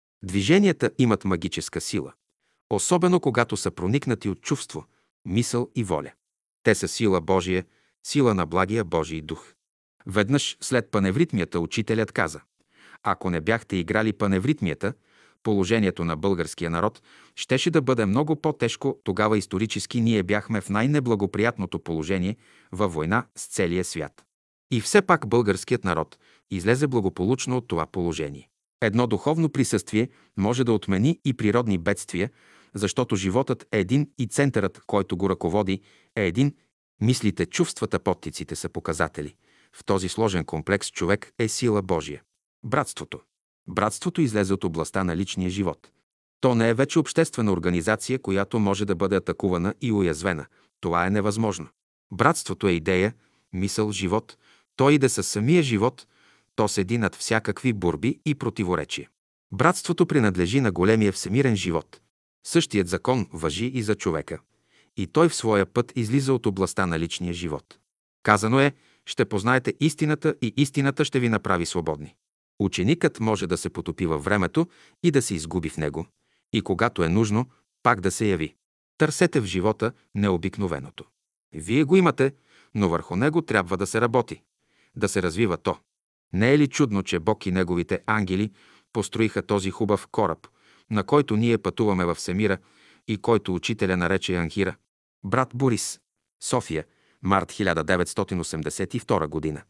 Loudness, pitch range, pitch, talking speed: -24 LUFS, 95-125 Hz, 105 Hz, 145 wpm